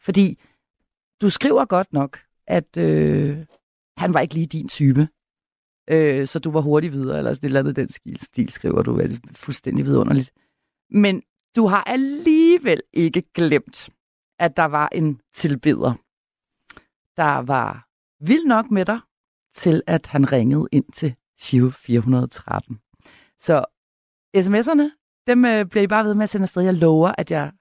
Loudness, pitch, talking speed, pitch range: -20 LUFS, 165 Hz, 165 wpm, 140-205 Hz